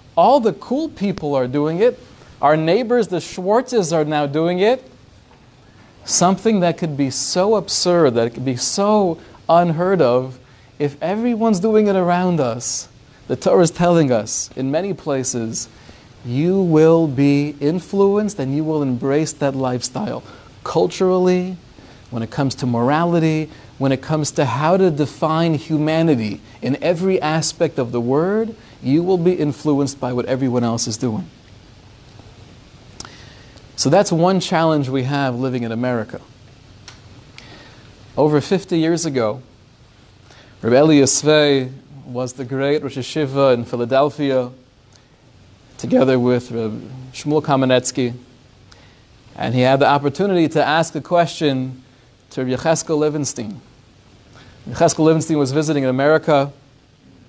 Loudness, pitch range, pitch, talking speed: -18 LUFS, 125-165 Hz, 140 Hz, 135 wpm